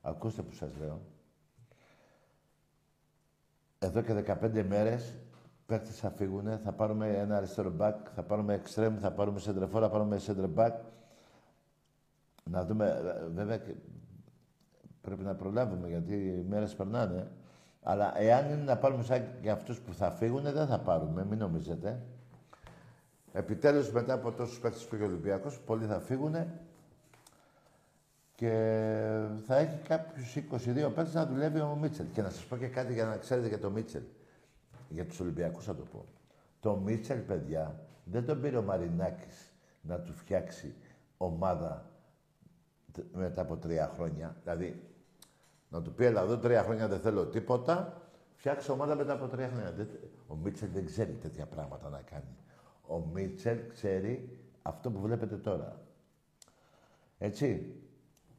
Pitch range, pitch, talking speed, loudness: 100-130 Hz, 110 Hz, 145 wpm, -34 LUFS